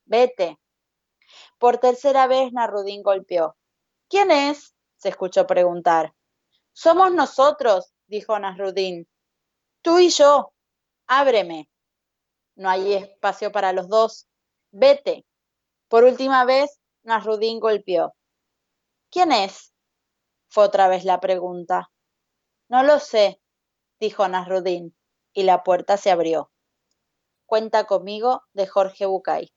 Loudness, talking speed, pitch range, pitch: -20 LUFS, 110 wpm, 185-255 Hz, 205 Hz